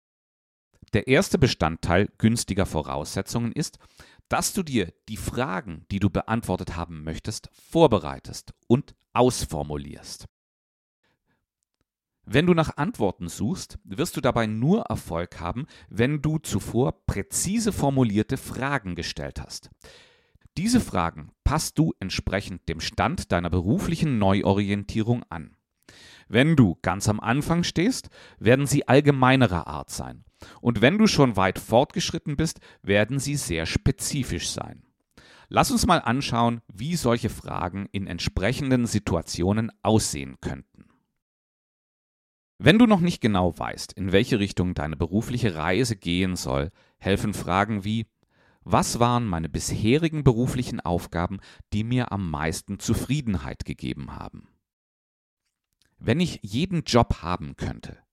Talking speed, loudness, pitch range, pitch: 125 wpm, -24 LUFS, 85-125 Hz, 105 Hz